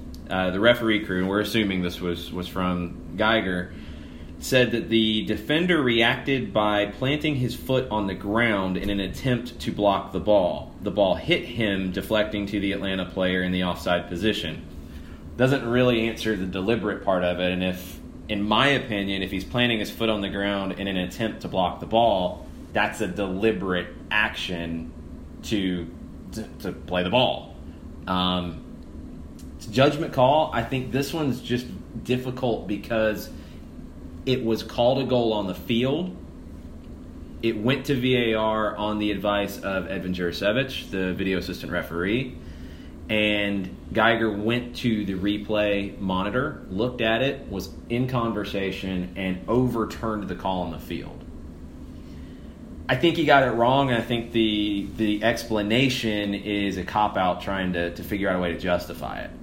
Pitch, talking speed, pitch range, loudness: 100 Hz, 165 wpm, 90-115 Hz, -24 LUFS